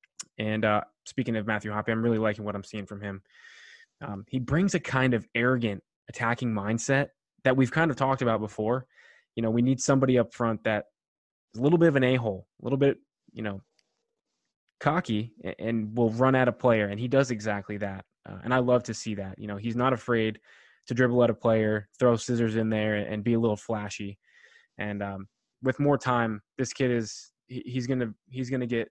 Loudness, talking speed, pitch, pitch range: -27 LUFS, 210 wpm, 115 Hz, 105-130 Hz